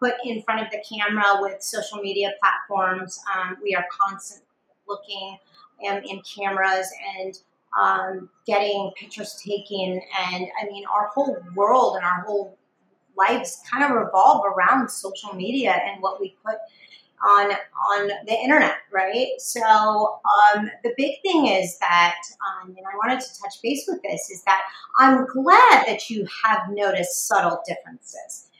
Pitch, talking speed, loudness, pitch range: 205 Hz, 155 wpm, -21 LUFS, 195-230 Hz